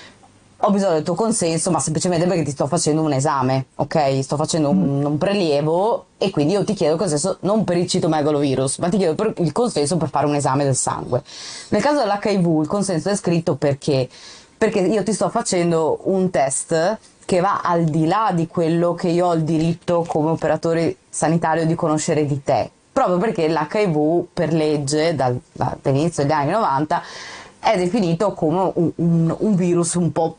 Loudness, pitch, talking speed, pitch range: -19 LUFS, 165 Hz, 190 wpm, 155-185 Hz